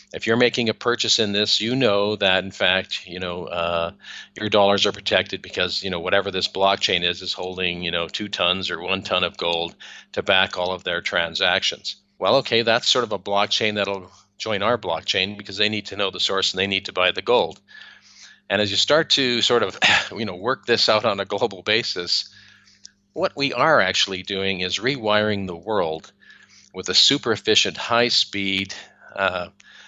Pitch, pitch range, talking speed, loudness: 100 Hz, 95-110 Hz, 200 wpm, -21 LUFS